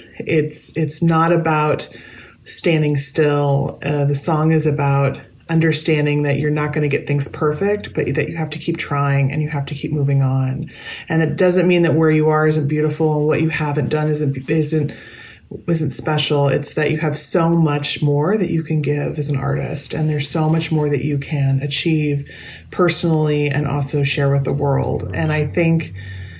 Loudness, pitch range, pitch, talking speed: -16 LUFS, 145-160 Hz, 150 Hz, 195 wpm